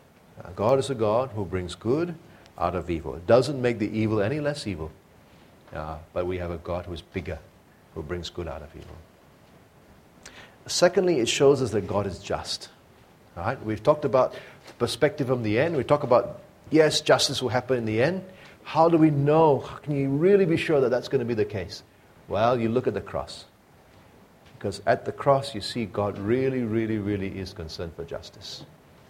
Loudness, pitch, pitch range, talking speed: -25 LUFS, 110 Hz, 95-140 Hz, 195 wpm